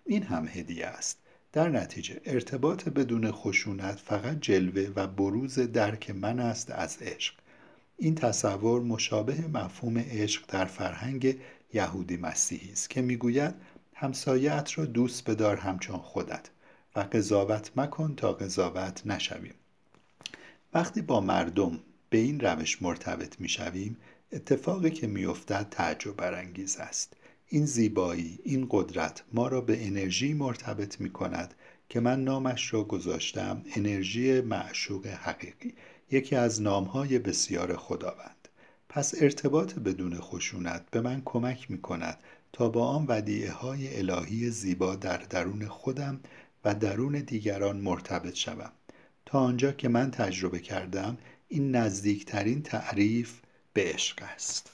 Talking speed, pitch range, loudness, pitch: 125 wpm, 100-130 Hz, -31 LUFS, 115 Hz